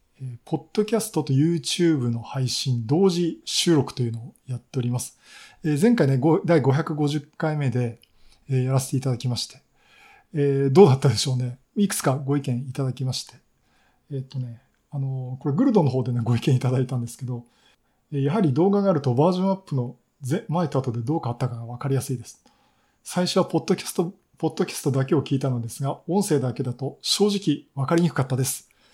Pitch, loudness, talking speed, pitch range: 140 Hz, -24 LUFS, 410 characters per minute, 125-165 Hz